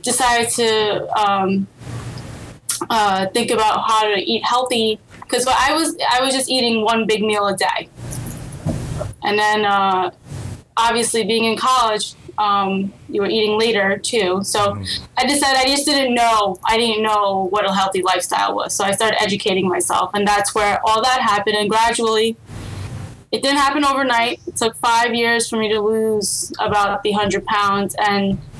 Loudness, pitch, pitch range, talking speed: -17 LUFS, 215 Hz, 200-235 Hz, 170 wpm